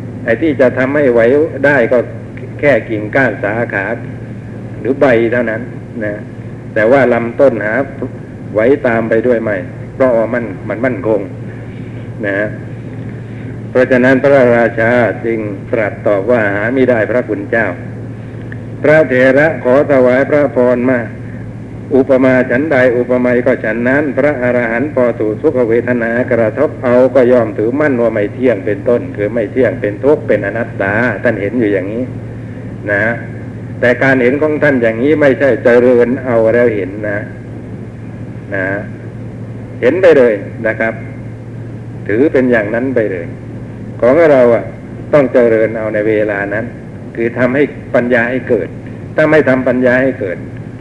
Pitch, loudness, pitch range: 120 Hz, -12 LUFS, 115-125 Hz